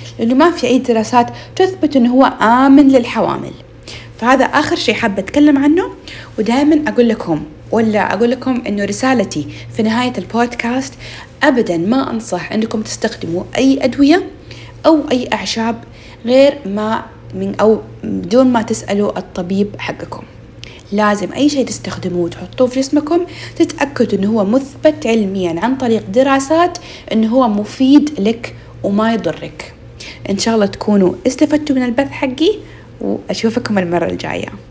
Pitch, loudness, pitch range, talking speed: 235 Hz, -14 LUFS, 205-270 Hz, 135 wpm